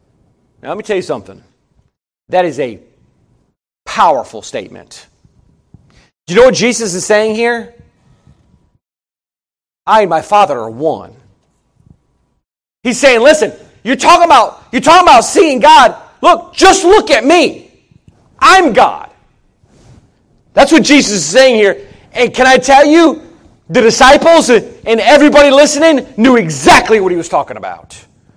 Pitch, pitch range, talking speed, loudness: 255 Hz, 210-300 Hz, 140 wpm, -8 LUFS